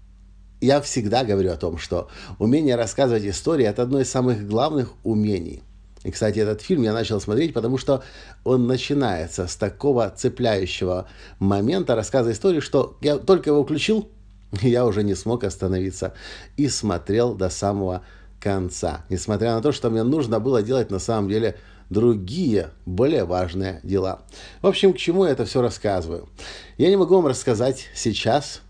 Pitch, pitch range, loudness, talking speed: 110 Hz, 95-130 Hz, -22 LUFS, 160 wpm